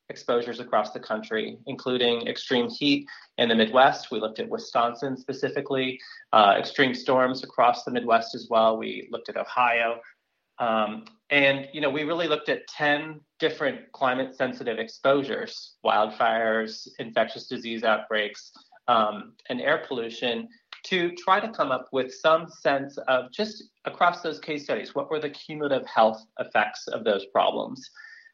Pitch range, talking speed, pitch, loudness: 120-150 Hz, 150 wpm, 130 Hz, -25 LUFS